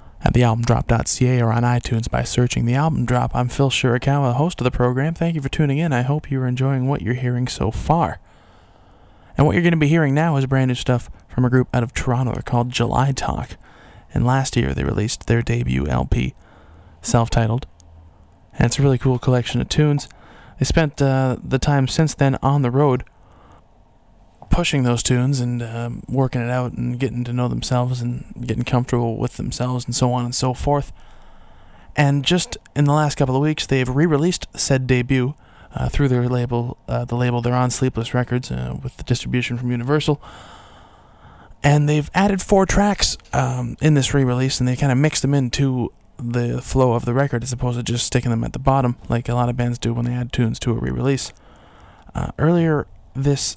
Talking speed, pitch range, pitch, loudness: 205 wpm, 120-140 Hz, 125 Hz, -20 LUFS